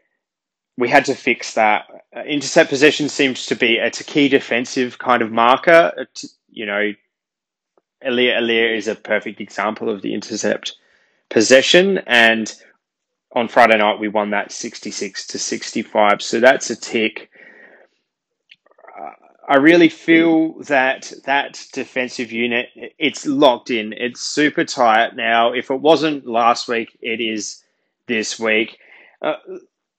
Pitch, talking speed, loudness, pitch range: 125 Hz, 130 wpm, -17 LUFS, 115-140 Hz